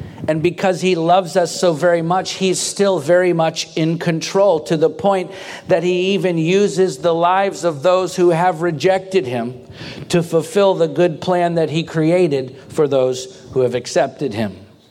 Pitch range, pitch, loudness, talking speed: 155-185 Hz, 175 Hz, -17 LUFS, 175 wpm